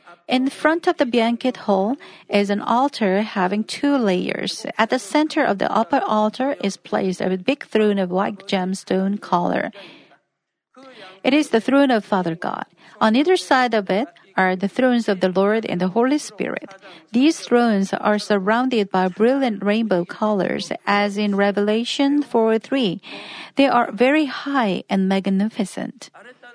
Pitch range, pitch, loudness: 195-260 Hz, 215 Hz, -20 LUFS